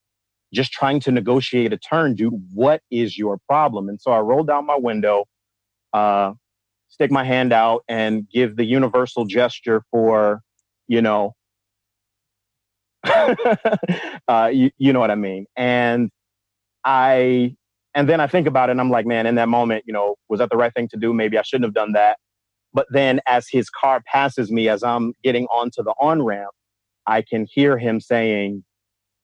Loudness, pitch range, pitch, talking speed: -19 LUFS, 105-130 Hz, 115 Hz, 180 wpm